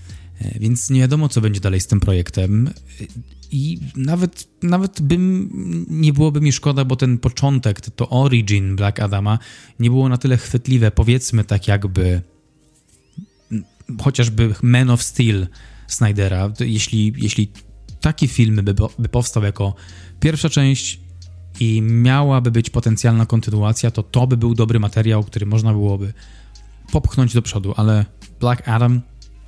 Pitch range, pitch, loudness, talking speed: 100-125 Hz, 115 Hz, -17 LUFS, 135 wpm